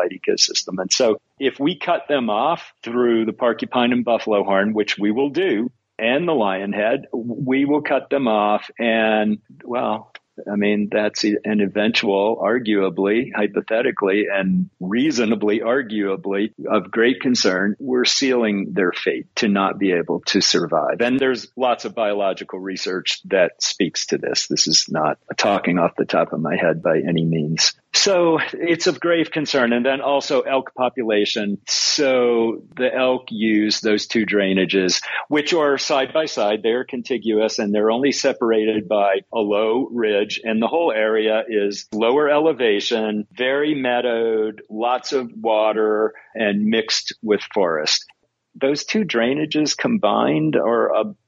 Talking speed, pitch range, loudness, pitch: 150 wpm, 105-130 Hz, -19 LUFS, 110 Hz